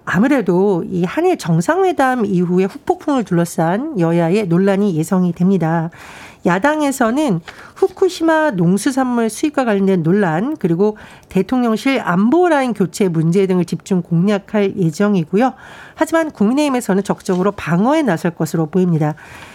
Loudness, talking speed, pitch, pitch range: -16 LUFS, 330 characters per minute, 200 Hz, 175-260 Hz